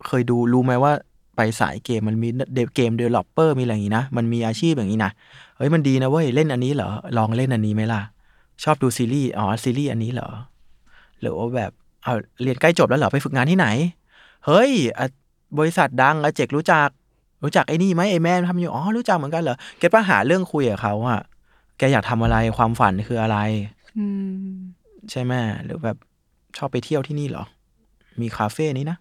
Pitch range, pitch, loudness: 115-155 Hz, 130 Hz, -21 LUFS